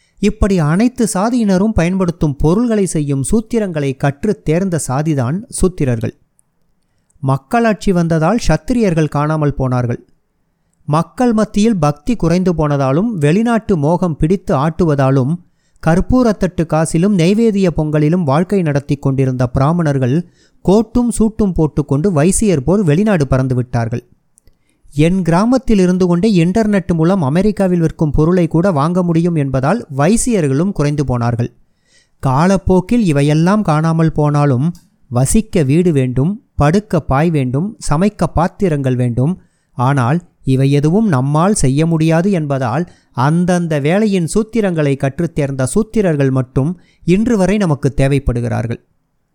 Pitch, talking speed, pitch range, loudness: 165 Hz, 105 wpm, 145-195 Hz, -14 LUFS